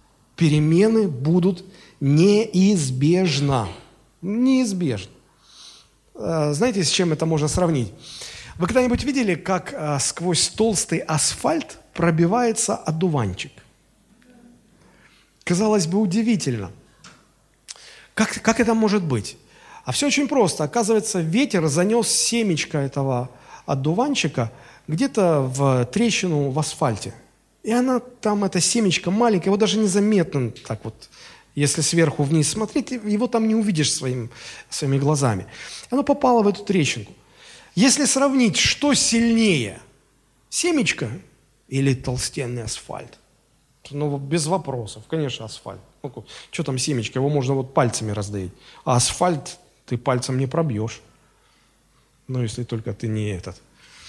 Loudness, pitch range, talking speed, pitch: -21 LUFS, 130-215 Hz, 115 wpm, 160 Hz